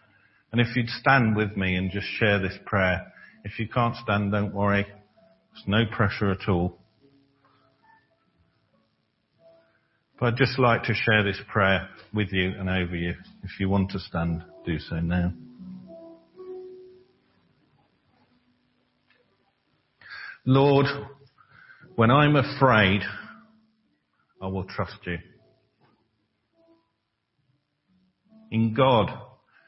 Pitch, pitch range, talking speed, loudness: 110 Hz, 100-140 Hz, 105 wpm, -24 LUFS